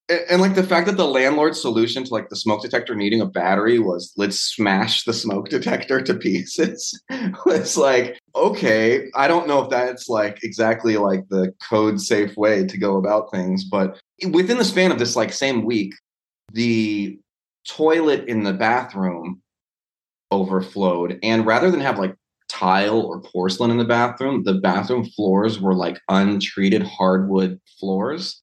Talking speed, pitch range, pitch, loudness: 165 wpm, 95-135 Hz, 110 Hz, -20 LUFS